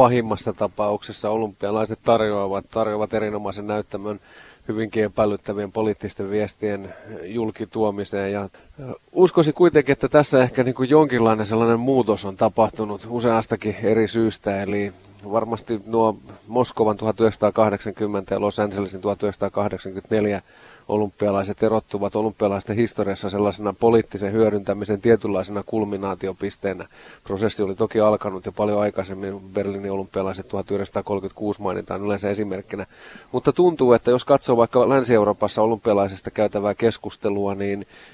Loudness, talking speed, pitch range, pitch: -22 LUFS, 110 wpm, 100-115 Hz, 105 Hz